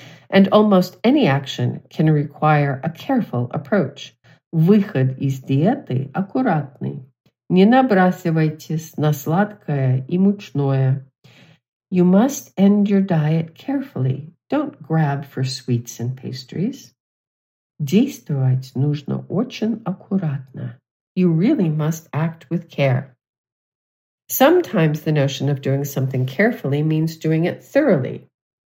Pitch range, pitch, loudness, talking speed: 135-190 Hz, 155 Hz, -19 LUFS, 110 wpm